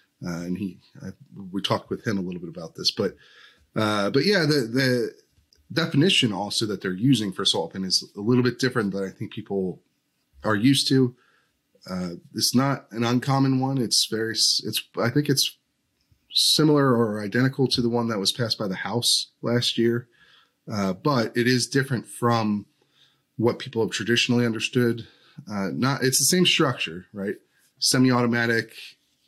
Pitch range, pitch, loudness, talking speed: 105-135 Hz, 120 Hz, -23 LUFS, 170 wpm